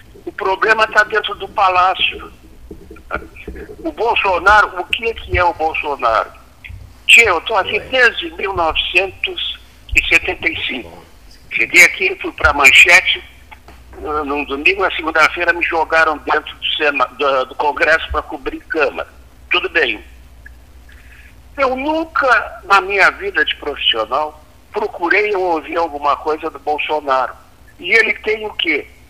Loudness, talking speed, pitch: -14 LUFS, 125 wpm, 175 Hz